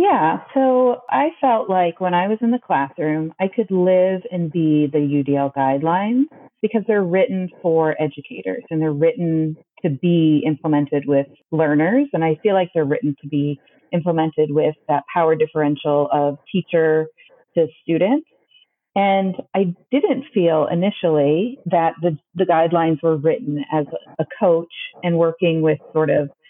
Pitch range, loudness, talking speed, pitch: 155-190 Hz, -19 LUFS, 155 wpm, 165 Hz